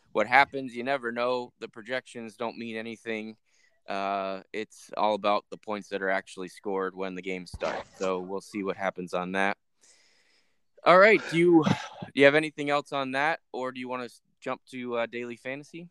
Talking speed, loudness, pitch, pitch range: 195 wpm, -28 LUFS, 115 Hz, 95-130 Hz